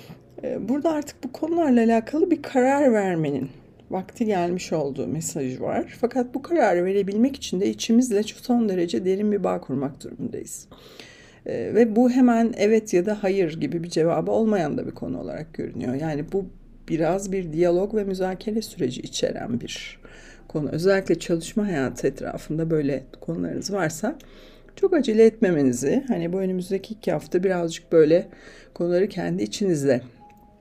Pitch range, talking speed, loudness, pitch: 165-230 Hz, 145 wpm, -23 LUFS, 190 Hz